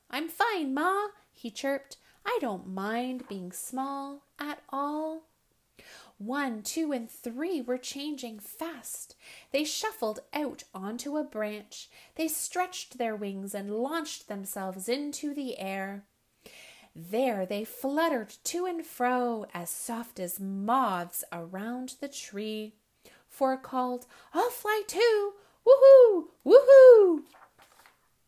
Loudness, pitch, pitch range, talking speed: -27 LUFS, 265 Hz, 215-320 Hz, 115 wpm